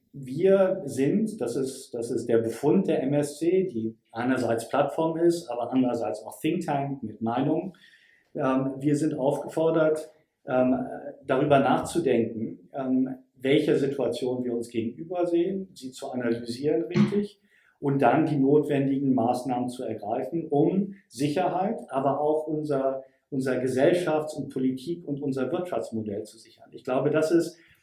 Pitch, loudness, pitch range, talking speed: 140 Hz, -26 LUFS, 125-160 Hz, 140 wpm